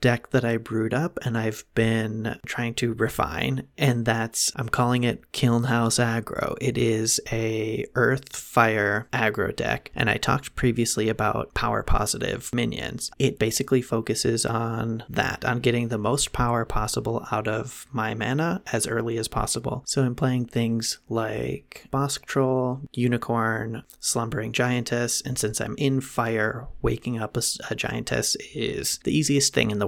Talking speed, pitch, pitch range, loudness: 160 wpm, 115 Hz, 110-125 Hz, -25 LUFS